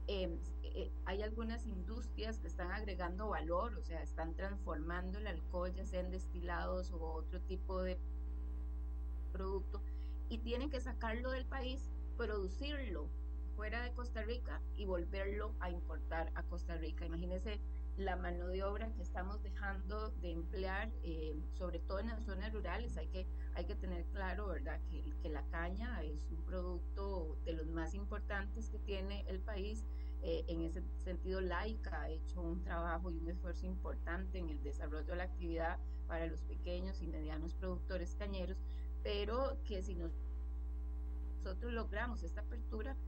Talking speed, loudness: 160 wpm, -44 LUFS